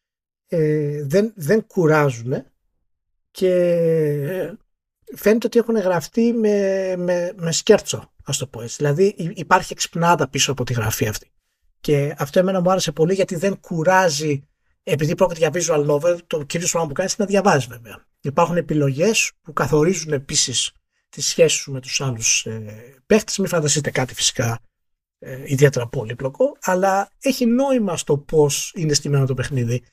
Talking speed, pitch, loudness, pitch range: 155 wpm, 155 Hz, -19 LUFS, 135-185 Hz